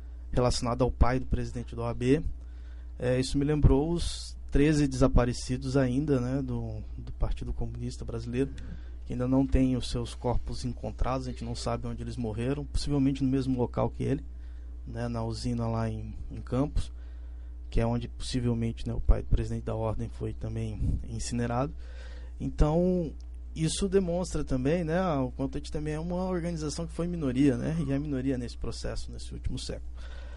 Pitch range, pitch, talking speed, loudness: 85-135 Hz, 120 Hz, 175 wpm, -31 LUFS